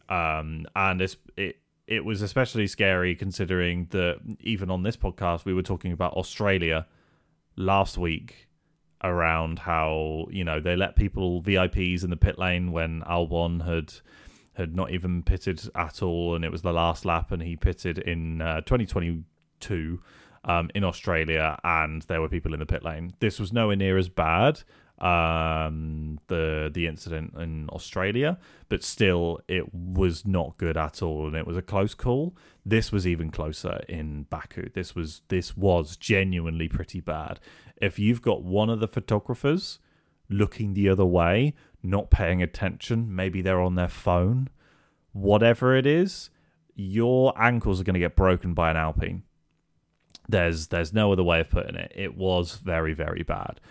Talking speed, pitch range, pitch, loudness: 165 wpm, 85-100 Hz, 90 Hz, -26 LUFS